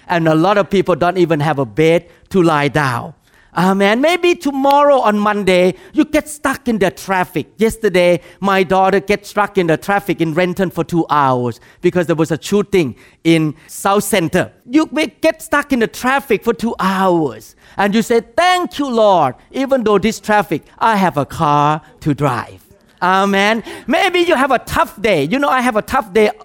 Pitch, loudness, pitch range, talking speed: 190 Hz, -15 LUFS, 165-230 Hz, 195 wpm